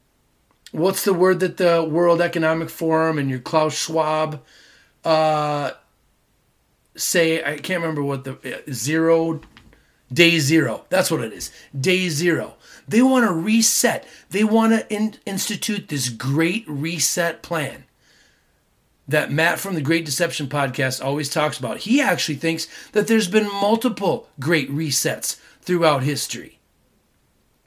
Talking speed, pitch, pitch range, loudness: 135 wpm, 165 Hz, 145-185 Hz, -20 LUFS